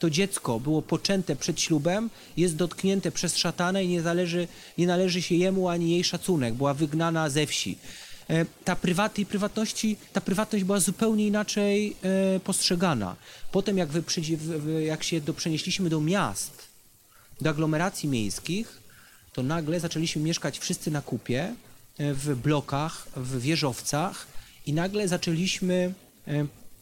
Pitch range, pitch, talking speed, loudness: 155-190 Hz, 170 Hz, 130 wpm, -27 LUFS